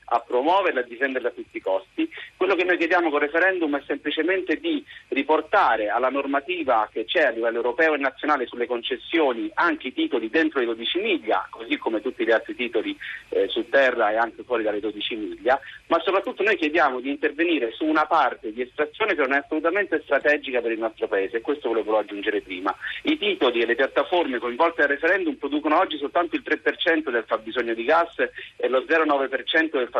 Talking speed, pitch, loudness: 200 wpm, 155 Hz, -23 LUFS